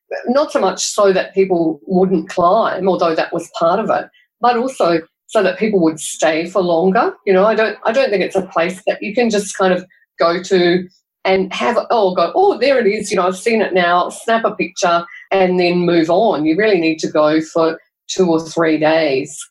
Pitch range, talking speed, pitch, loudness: 170-210 Hz, 220 wpm, 185 Hz, -15 LUFS